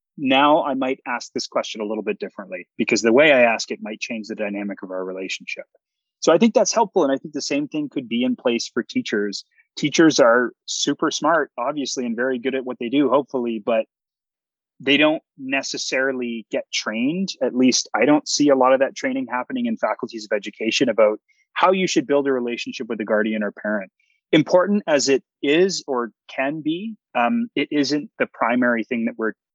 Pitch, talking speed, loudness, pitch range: 135 Hz, 205 wpm, -21 LUFS, 120-175 Hz